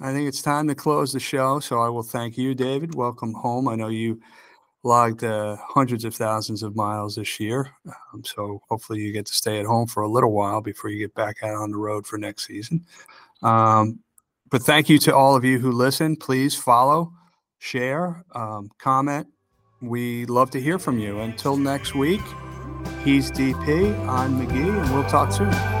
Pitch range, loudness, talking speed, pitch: 110-135 Hz, -22 LUFS, 195 wpm, 120 Hz